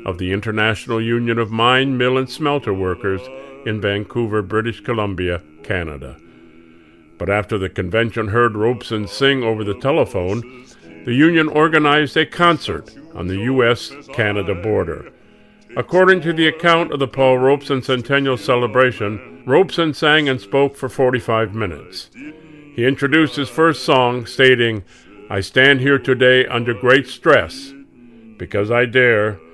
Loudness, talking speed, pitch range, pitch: -17 LUFS, 140 wpm, 105-140 Hz, 120 Hz